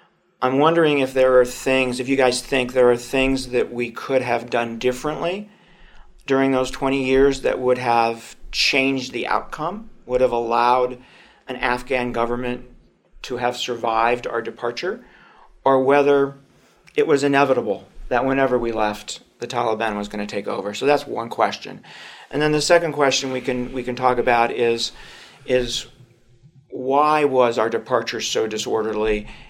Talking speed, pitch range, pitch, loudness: 160 wpm, 120-135 Hz, 125 Hz, -20 LUFS